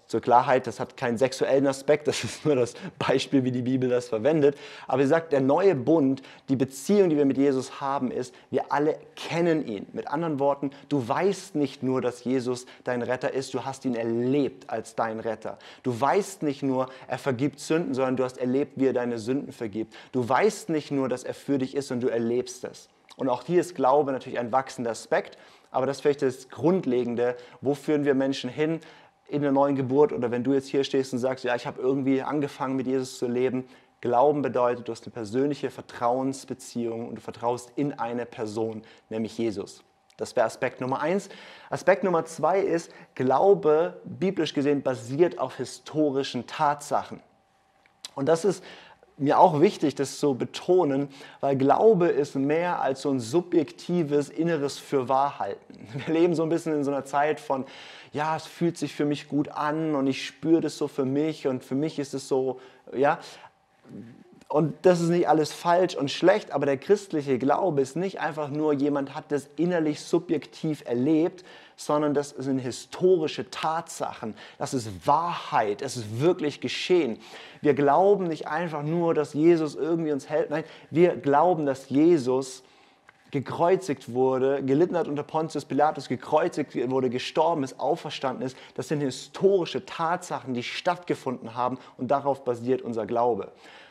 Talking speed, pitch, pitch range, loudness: 180 wpm, 140 Hz, 130-155 Hz, -26 LUFS